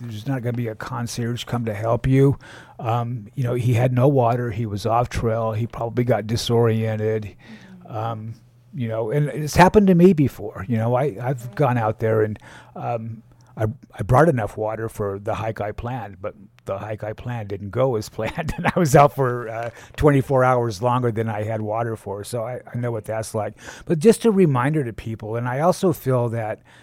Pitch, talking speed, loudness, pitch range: 115 Hz, 210 wpm, -21 LUFS, 110-125 Hz